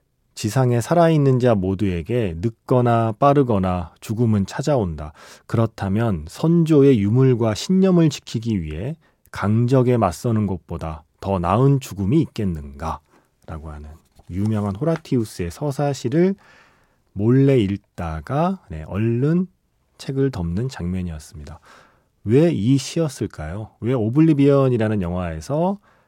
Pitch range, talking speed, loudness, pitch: 95-140 Hz, 270 characters per minute, -20 LUFS, 115 Hz